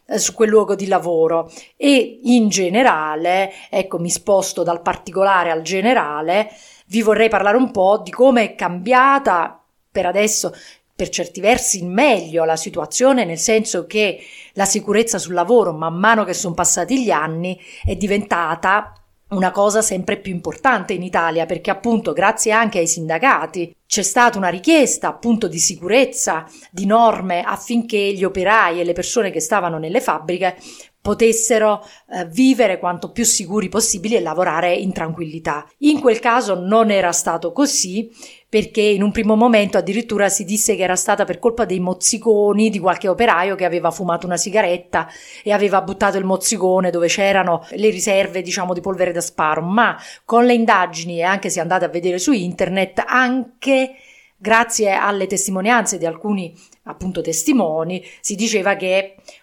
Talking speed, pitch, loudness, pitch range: 160 wpm, 195 Hz, -17 LUFS, 180-225 Hz